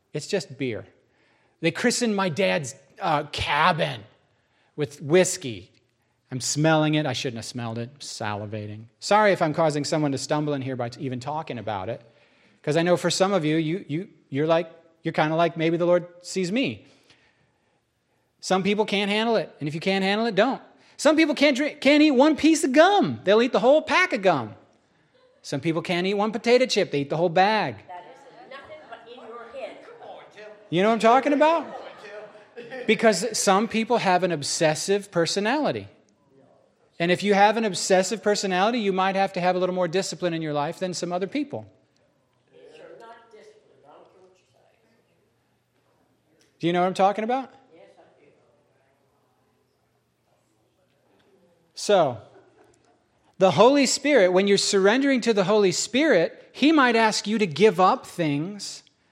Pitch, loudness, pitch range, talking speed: 190 Hz, -22 LUFS, 155-230 Hz, 160 wpm